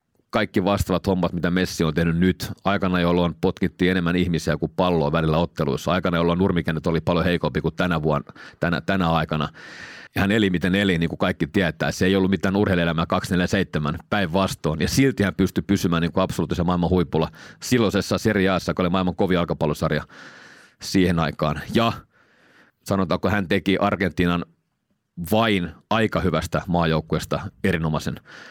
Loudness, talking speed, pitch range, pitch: -22 LUFS, 155 wpm, 85-95 Hz, 90 Hz